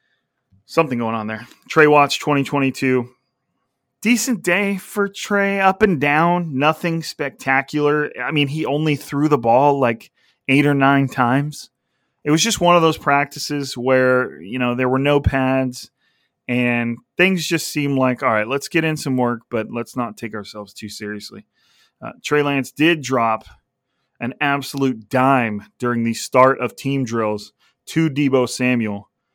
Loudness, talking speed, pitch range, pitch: -18 LUFS, 160 wpm, 120-150 Hz, 135 Hz